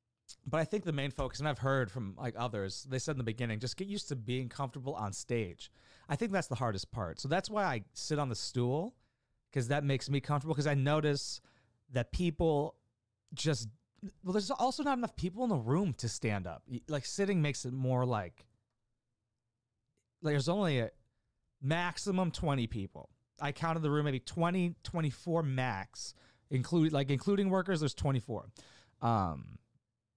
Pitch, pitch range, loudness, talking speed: 130 Hz, 115-155 Hz, -35 LUFS, 180 wpm